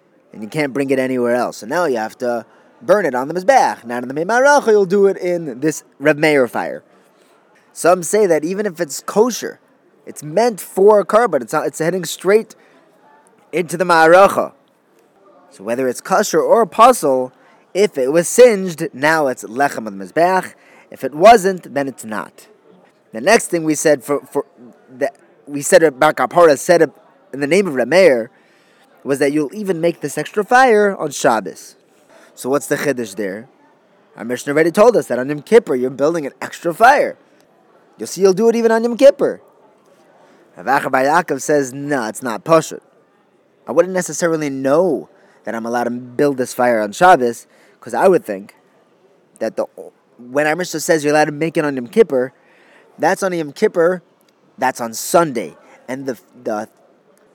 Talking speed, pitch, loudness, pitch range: 185 wpm, 155 Hz, -15 LUFS, 135-185 Hz